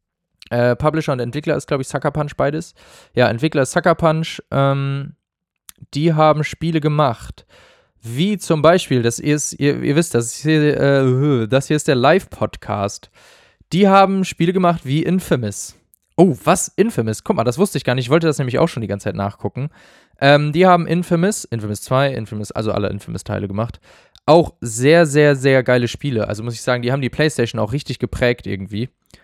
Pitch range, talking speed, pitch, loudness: 115-155 Hz, 190 wpm, 140 Hz, -17 LUFS